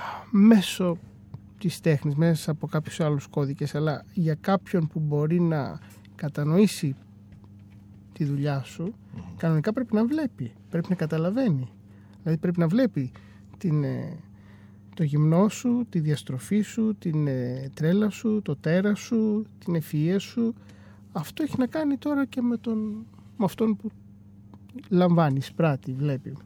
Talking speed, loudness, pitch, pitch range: 135 wpm, -26 LUFS, 160 Hz, 130-205 Hz